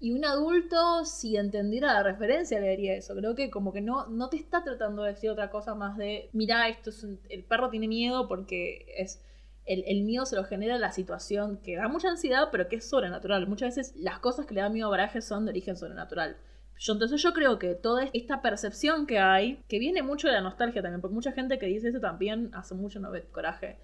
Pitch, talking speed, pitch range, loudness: 220 Hz, 235 wpm, 200-260 Hz, -30 LUFS